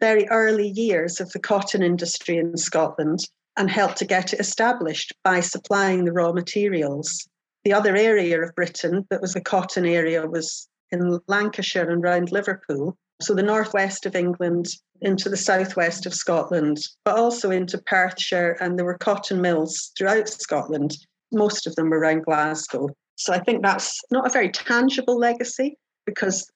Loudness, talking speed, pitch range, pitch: -22 LUFS, 165 wpm, 170-205 Hz, 185 Hz